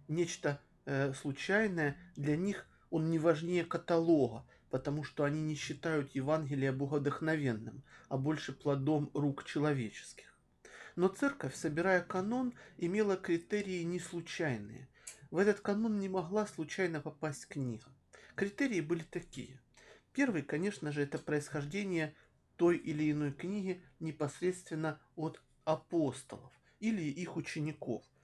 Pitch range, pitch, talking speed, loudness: 145-180 Hz, 155 Hz, 115 wpm, -36 LUFS